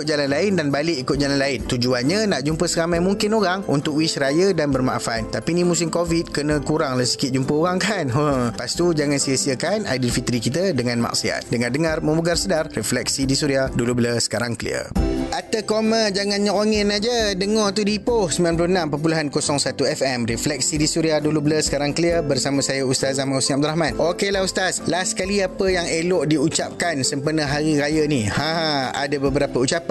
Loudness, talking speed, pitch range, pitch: -20 LUFS, 180 wpm, 135-175 Hz, 155 Hz